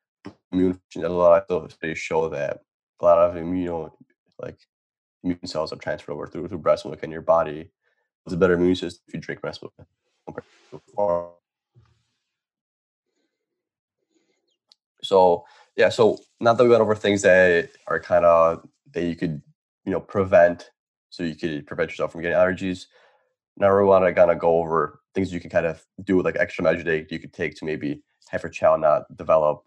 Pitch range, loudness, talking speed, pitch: 85-100 Hz, -22 LUFS, 180 wpm, 90 Hz